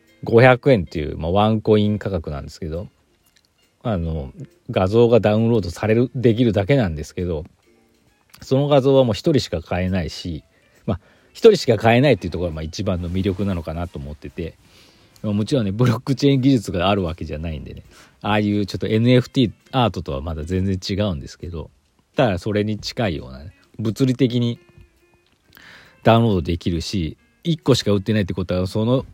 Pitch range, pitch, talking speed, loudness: 90-120 Hz, 105 Hz, 390 characters per minute, -20 LUFS